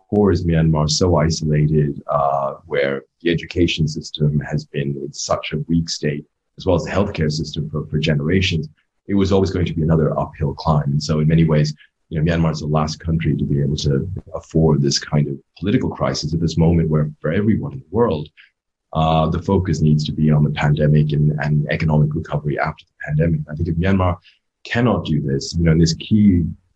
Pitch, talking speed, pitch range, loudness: 80 Hz, 210 wpm, 75-85 Hz, -19 LUFS